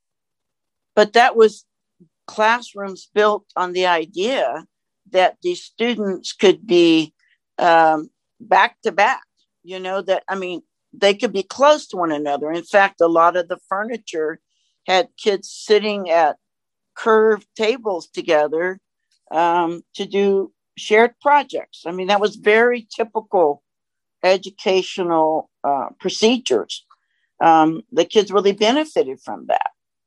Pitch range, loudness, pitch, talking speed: 170-220 Hz, -18 LUFS, 195 Hz, 125 wpm